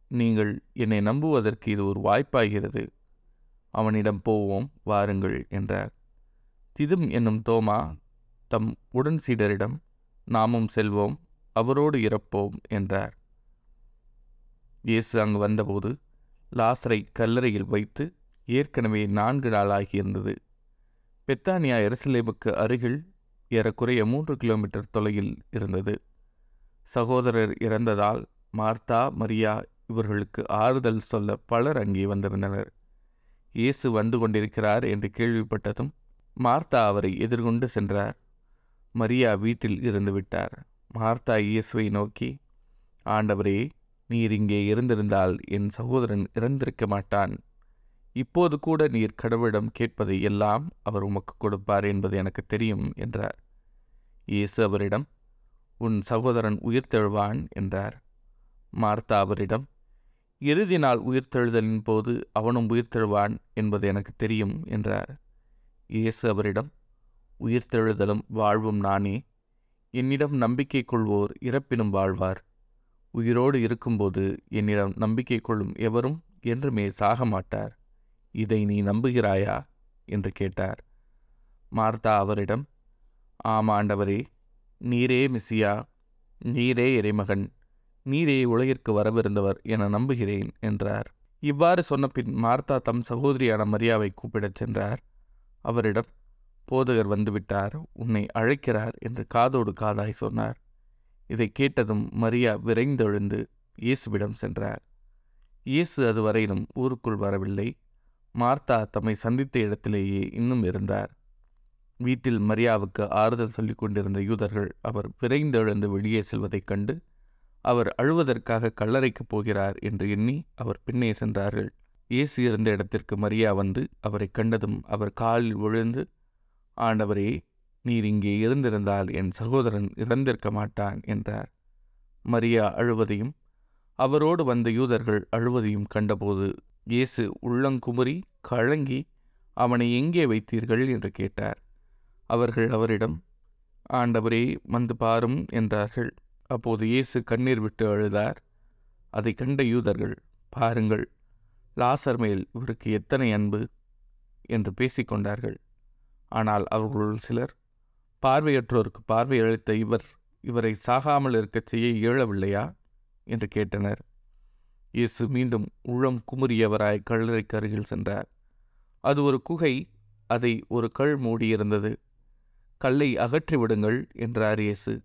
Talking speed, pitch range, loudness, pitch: 95 wpm, 105-120 Hz, -26 LUFS, 115 Hz